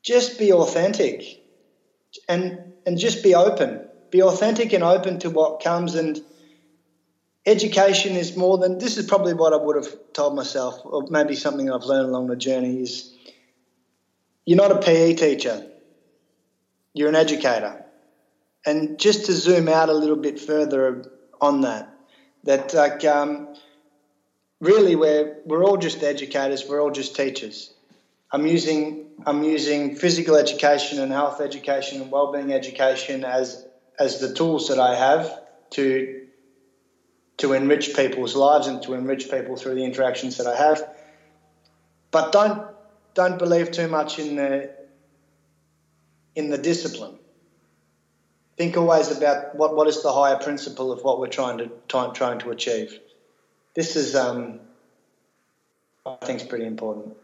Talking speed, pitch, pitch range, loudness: 145 wpm, 145 Hz, 135-165 Hz, -21 LUFS